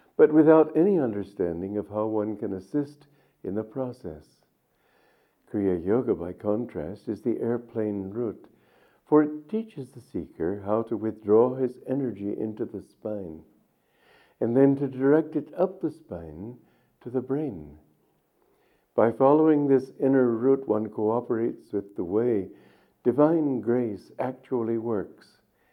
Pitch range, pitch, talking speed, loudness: 105-135 Hz, 120 Hz, 135 wpm, -26 LUFS